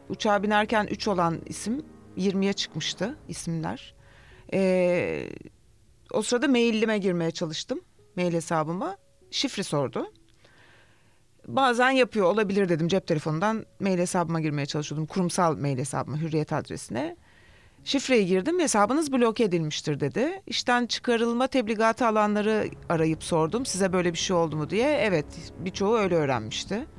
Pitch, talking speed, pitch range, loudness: 190 Hz, 125 wpm, 160-230 Hz, -26 LUFS